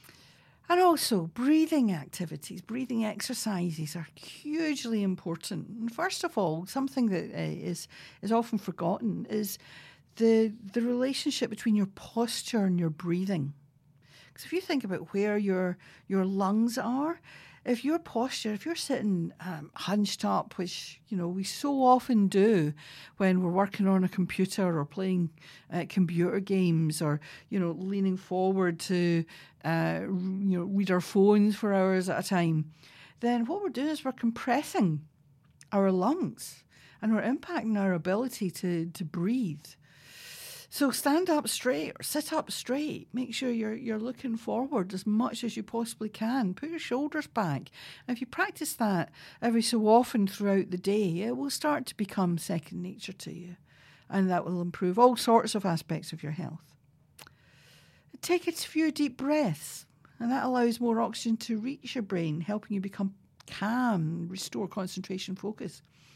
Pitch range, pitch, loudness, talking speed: 175-235 Hz, 195 Hz, -30 LUFS, 160 wpm